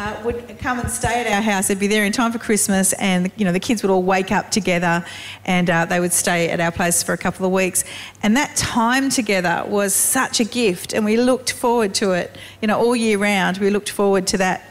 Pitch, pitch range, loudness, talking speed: 200 Hz, 185-230 Hz, -18 LUFS, 255 wpm